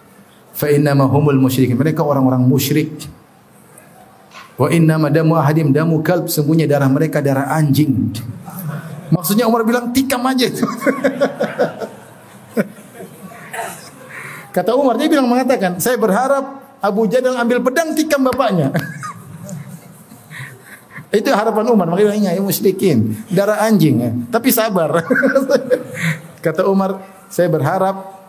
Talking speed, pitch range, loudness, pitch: 115 wpm, 155-240 Hz, -15 LUFS, 190 Hz